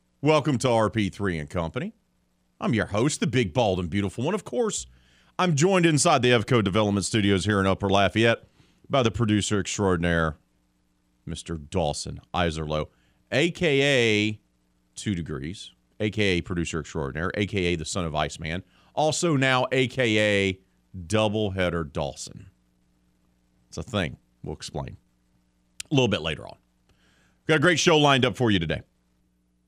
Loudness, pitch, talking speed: -24 LUFS, 90 Hz, 145 wpm